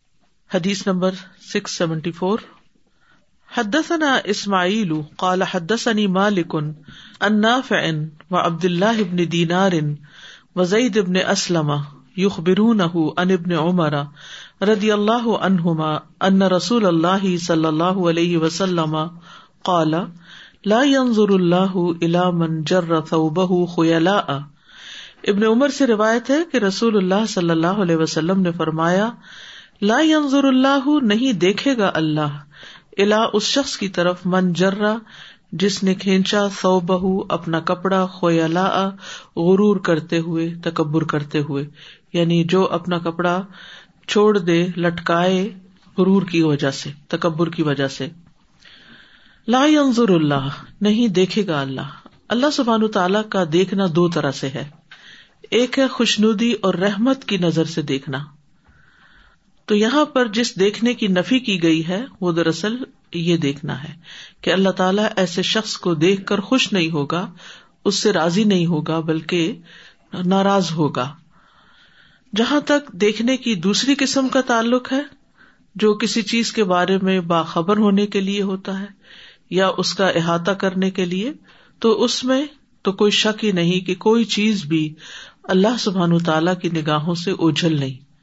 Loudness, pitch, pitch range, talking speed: -19 LUFS, 185 Hz, 170-215 Hz, 130 wpm